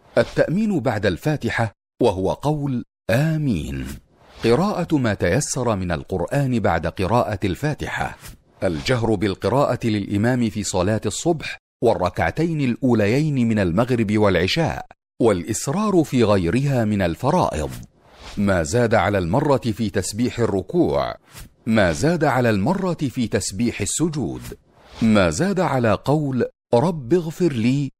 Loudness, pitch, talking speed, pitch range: -21 LUFS, 115 Hz, 110 wpm, 100-140 Hz